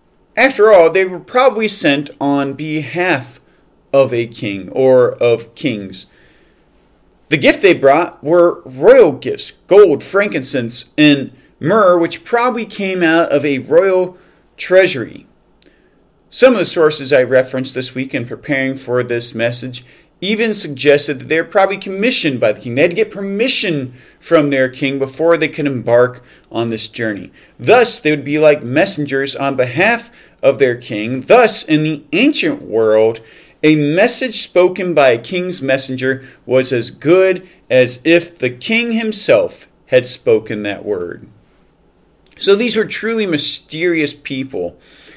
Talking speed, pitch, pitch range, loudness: 150 wpm, 155 Hz, 130-200 Hz, -13 LUFS